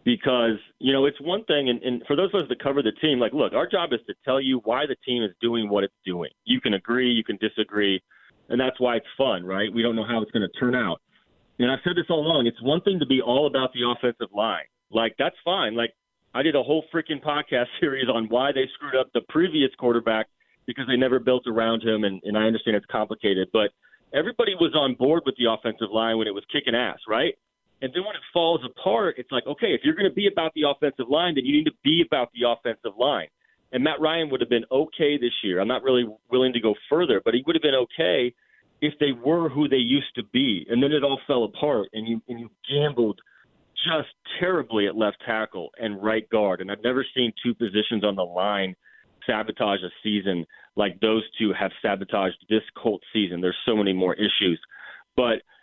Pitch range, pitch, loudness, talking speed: 110-145 Hz, 120 Hz, -24 LUFS, 235 wpm